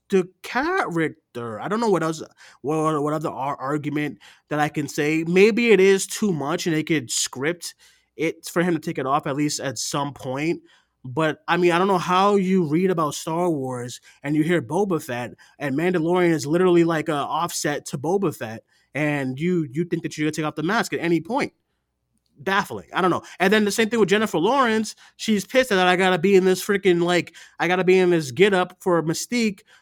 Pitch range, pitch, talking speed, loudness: 150-190 Hz, 170 Hz, 215 wpm, -22 LUFS